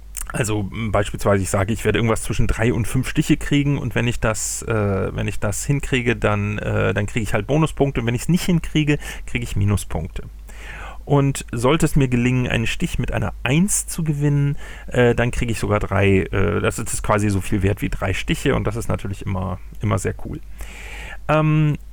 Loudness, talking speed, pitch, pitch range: -21 LUFS, 205 wpm, 115 Hz, 105-140 Hz